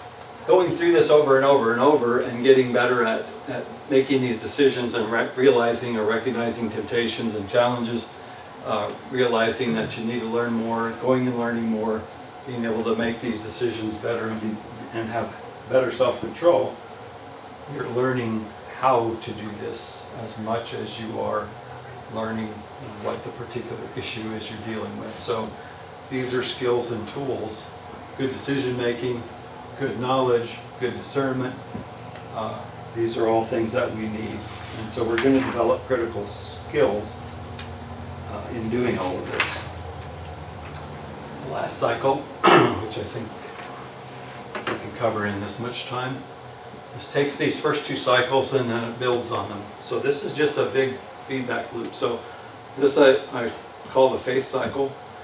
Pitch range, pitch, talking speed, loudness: 110-125 Hz, 115 Hz, 160 wpm, -24 LUFS